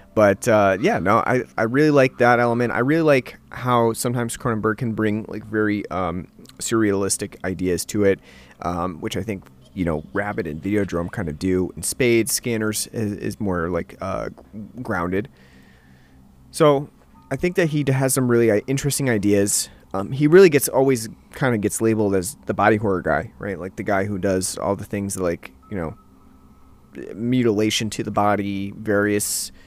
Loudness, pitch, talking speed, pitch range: -21 LUFS, 105 Hz, 175 wpm, 90-120 Hz